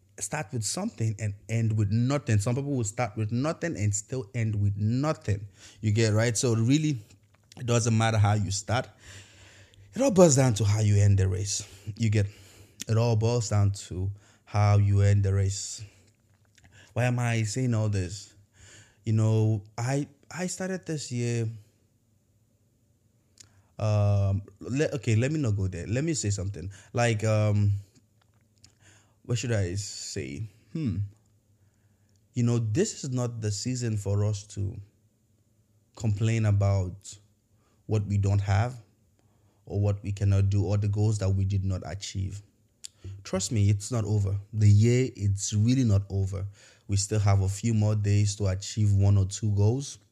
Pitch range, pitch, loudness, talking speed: 100-115 Hz, 105 Hz, -27 LUFS, 165 wpm